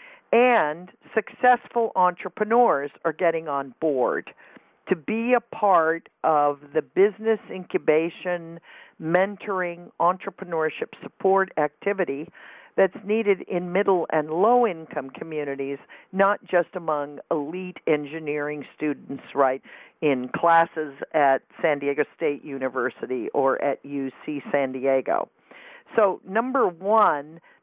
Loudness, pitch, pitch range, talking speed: -24 LUFS, 170 Hz, 145-195 Hz, 105 wpm